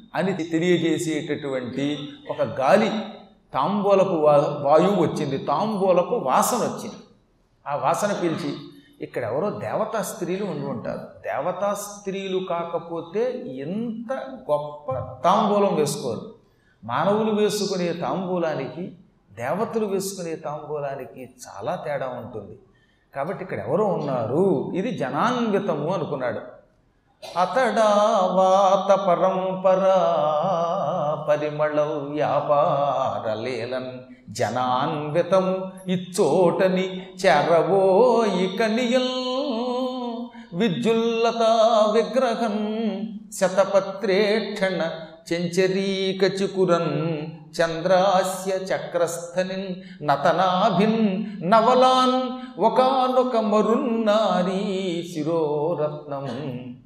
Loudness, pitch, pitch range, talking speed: -22 LUFS, 185 Hz, 155-210 Hz, 65 wpm